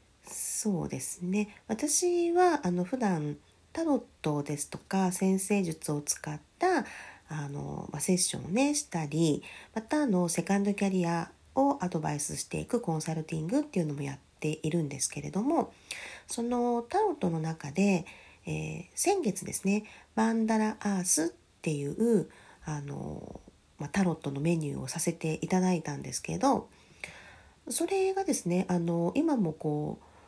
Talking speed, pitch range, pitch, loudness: 300 characters per minute, 160-225 Hz, 180 Hz, -31 LUFS